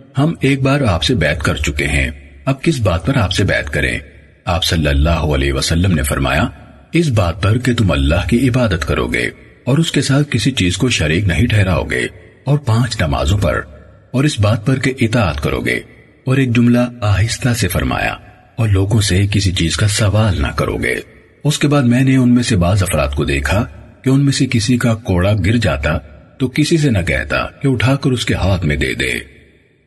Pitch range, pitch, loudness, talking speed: 80-125 Hz, 105 Hz, -15 LUFS, 215 wpm